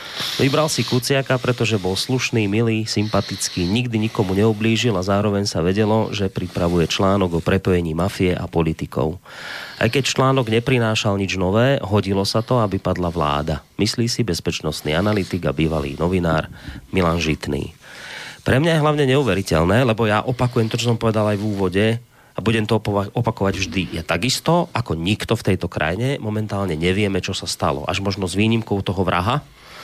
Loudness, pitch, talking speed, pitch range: -20 LUFS, 105 Hz, 165 wpm, 90-115 Hz